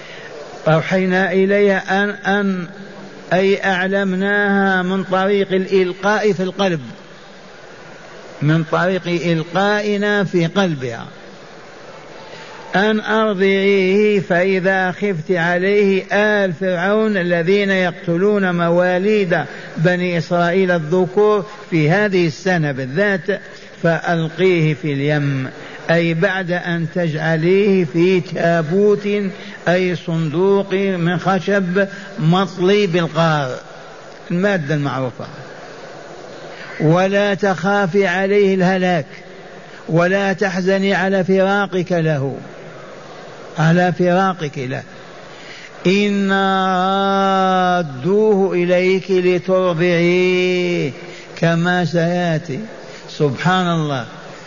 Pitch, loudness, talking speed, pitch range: 185 Hz, -16 LUFS, 75 wpm, 175-195 Hz